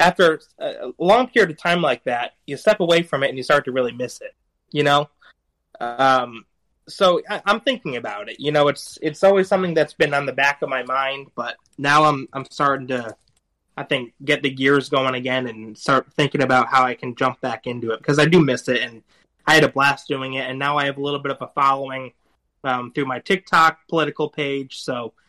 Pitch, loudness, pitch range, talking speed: 140 Hz, -20 LUFS, 130-150 Hz, 230 wpm